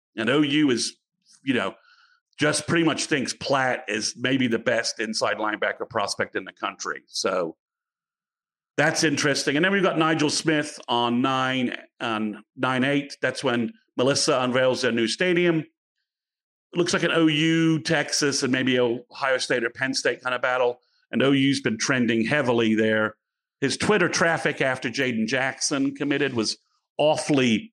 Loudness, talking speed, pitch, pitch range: -23 LUFS, 160 wpm, 140 Hz, 125-160 Hz